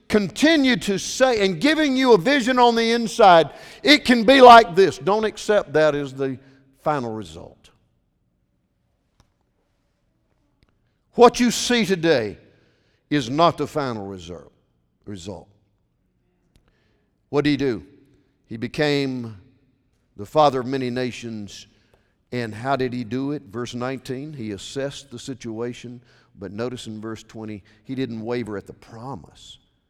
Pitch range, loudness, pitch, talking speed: 110-155 Hz, -19 LUFS, 130 Hz, 135 wpm